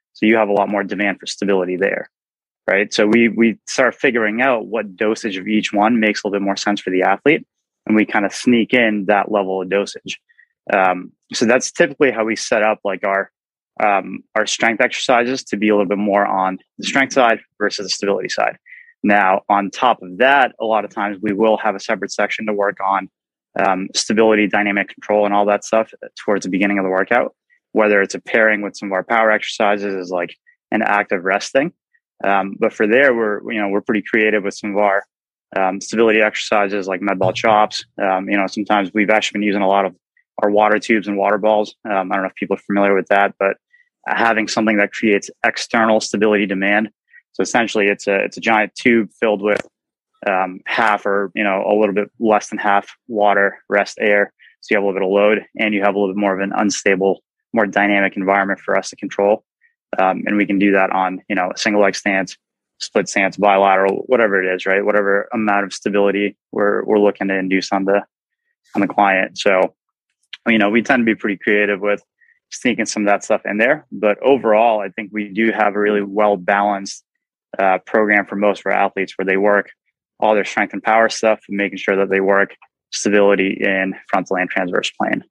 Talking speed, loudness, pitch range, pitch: 220 wpm, -17 LUFS, 100-110 Hz, 100 Hz